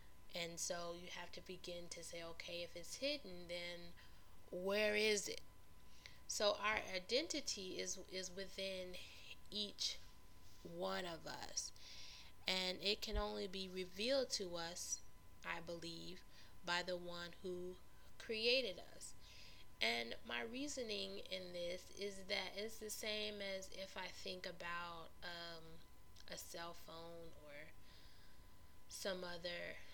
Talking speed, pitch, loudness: 130 wpm, 175 Hz, -45 LUFS